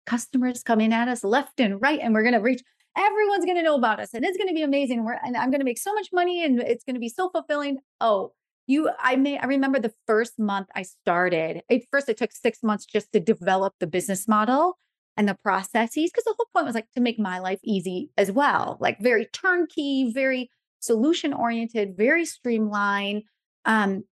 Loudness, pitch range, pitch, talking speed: -24 LUFS, 215-285 Hz, 240 Hz, 220 wpm